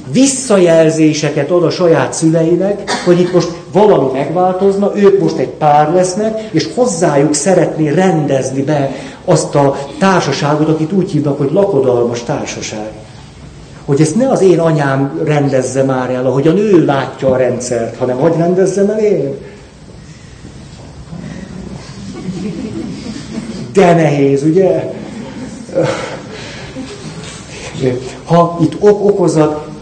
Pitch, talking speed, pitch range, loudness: 155 Hz, 115 wpm, 140-185 Hz, -12 LUFS